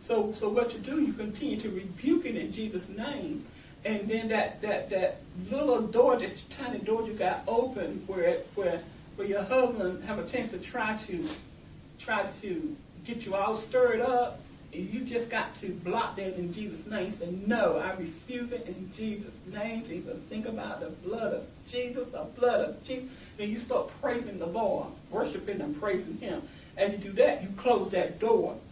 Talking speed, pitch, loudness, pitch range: 190 wpm, 220 Hz, -31 LUFS, 195-250 Hz